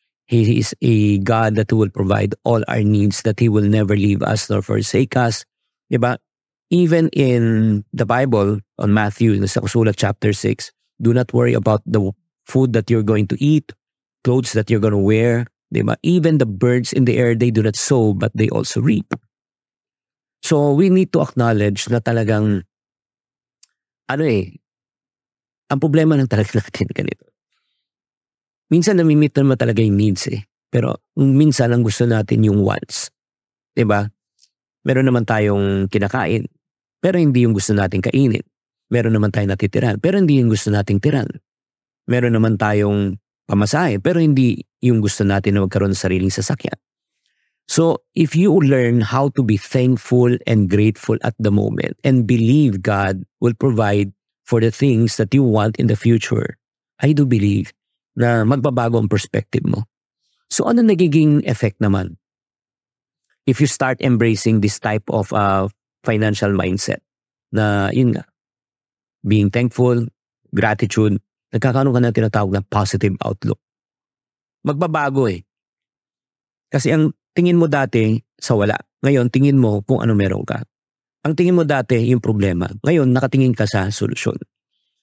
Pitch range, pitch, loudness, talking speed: 105-135 Hz, 115 Hz, -17 LUFS, 150 wpm